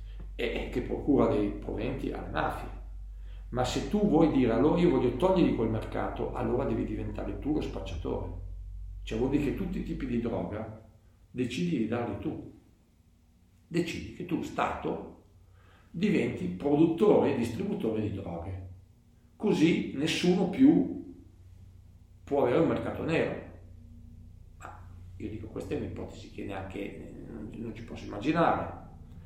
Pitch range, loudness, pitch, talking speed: 90-120 Hz, -30 LUFS, 100 Hz, 135 wpm